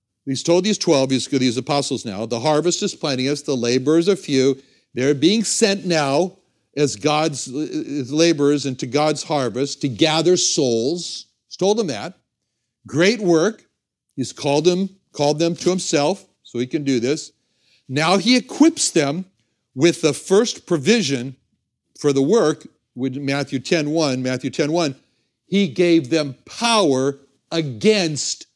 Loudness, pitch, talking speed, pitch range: -19 LUFS, 150 Hz, 145 wpm, 135-175 Hz